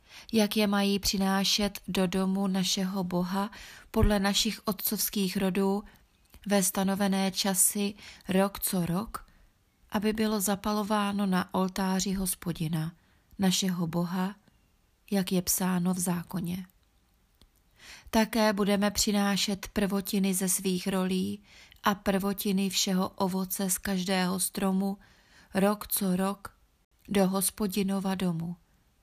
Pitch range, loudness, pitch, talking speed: 185-205 Hz, -28 LUFS, 195 Hz, 105 wpm